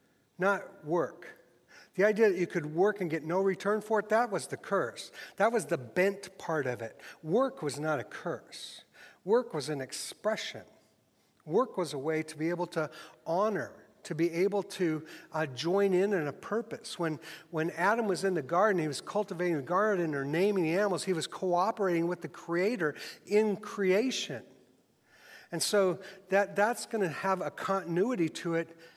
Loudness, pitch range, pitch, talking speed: -31 LUFS, 165-200 Hz, 185 Hz, 180 wpm